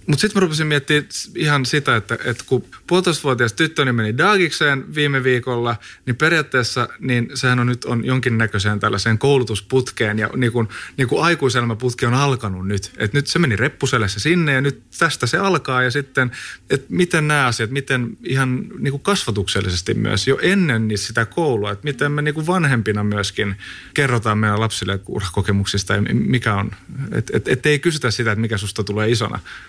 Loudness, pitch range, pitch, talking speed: -19 LUFS, 110-145 Hz, 125 Hz, 170 wpm